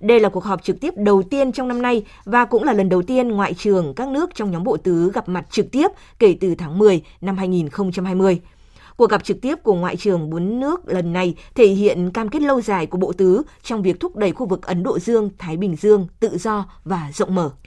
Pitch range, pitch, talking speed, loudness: 180-230 Hz, 195 Hz, 245 wpm, -19 LUFS